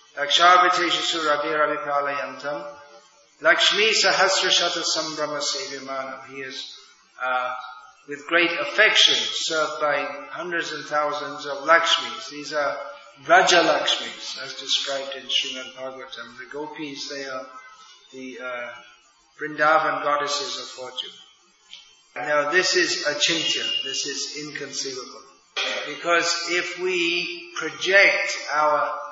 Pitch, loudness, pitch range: 150 Hz, -21 LUFS, 140-170 Hz